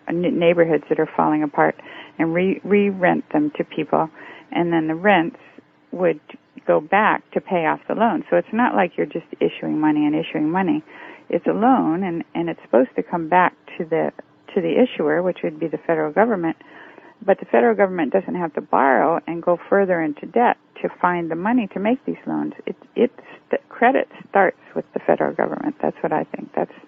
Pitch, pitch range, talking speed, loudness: 170 Hz, 160-200 Hz, 200 wpm, -20 LUFS